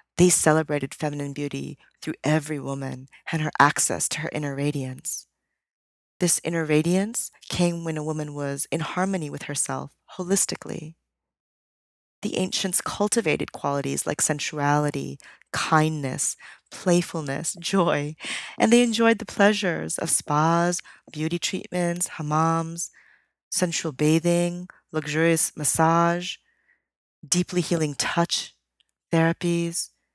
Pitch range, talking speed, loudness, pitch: 145-175 Hz, 105 wpm, -24 LUFS, 165 Hz